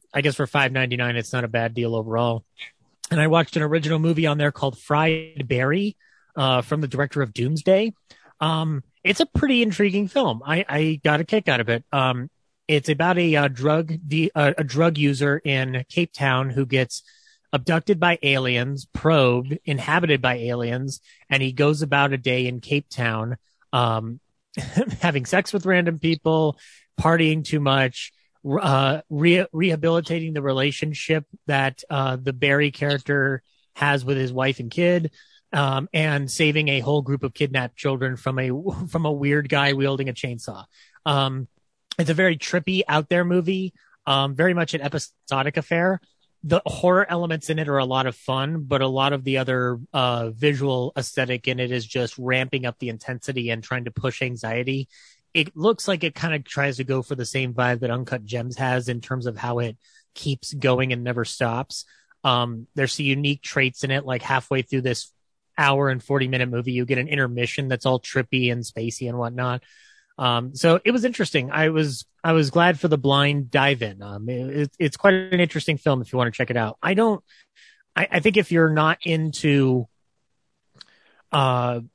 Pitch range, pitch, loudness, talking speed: 125-160 Hz, 140 Hz, -22 LUFS, 185 wpm